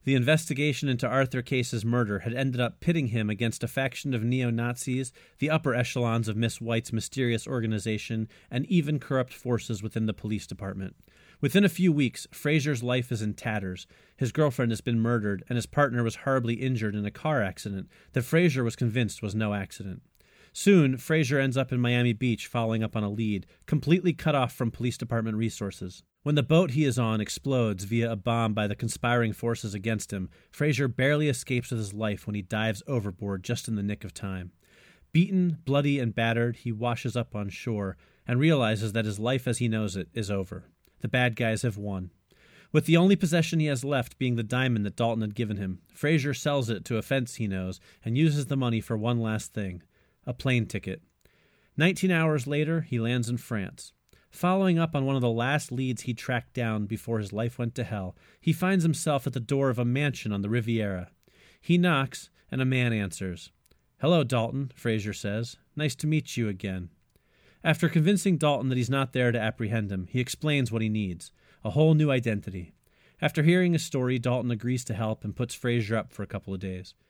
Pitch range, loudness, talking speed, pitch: 110-140 Hz, -28 LUFS, 200 wpm, 120 Hz